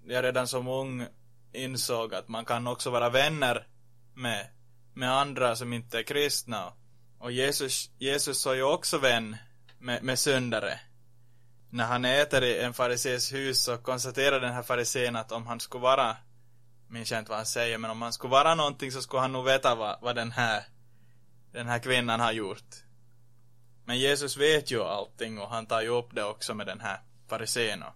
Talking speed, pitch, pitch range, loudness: 190 wpm, 120 Hz, 120-130 Hz, -29 LUFS